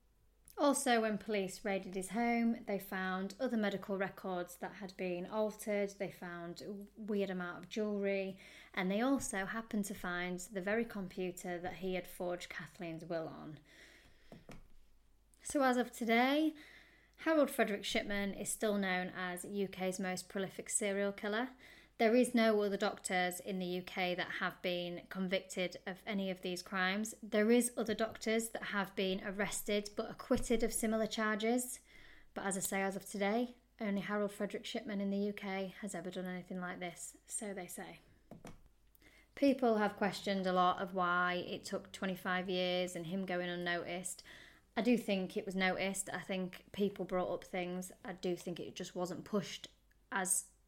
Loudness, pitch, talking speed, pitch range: -38 LUFS, 195 Hz, 170 wpm, 185-215 Hz